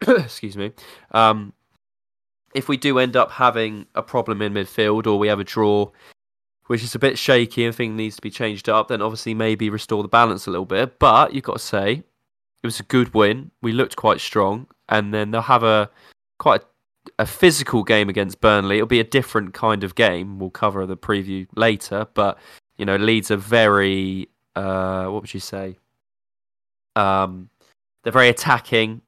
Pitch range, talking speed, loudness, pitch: 100-115 Hz, 190 wpm, -19 LUFS, 110 Hz